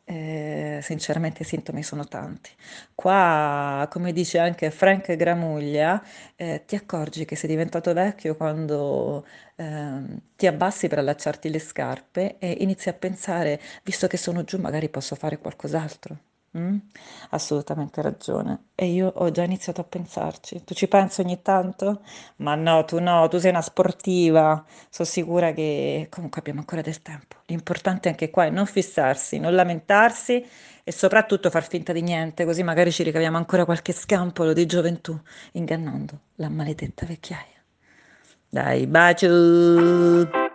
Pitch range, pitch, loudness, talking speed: 155-180 Hz, 170 Hz, -23 LUFS, 145 wpm